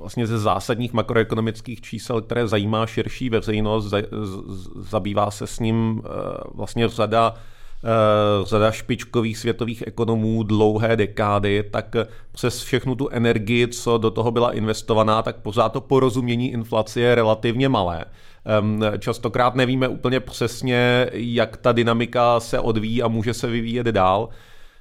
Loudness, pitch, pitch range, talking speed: -21 LUFS, 115 Hz, 110-120 Hz, 130 wpm